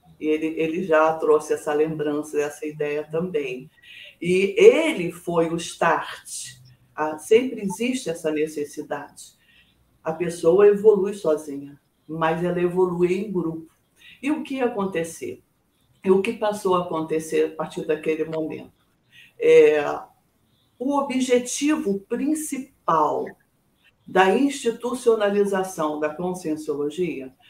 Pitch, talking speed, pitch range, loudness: 170 Hz, 110 wpm, 155-215 Hz, -22 LUFS